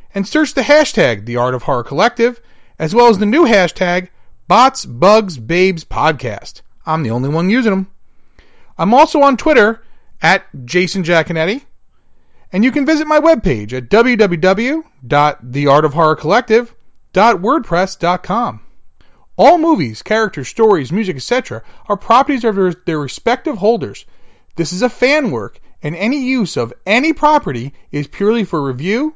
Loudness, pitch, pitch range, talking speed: -13 LUFS, 195 Hz, 155-240 Hz, 140 wpm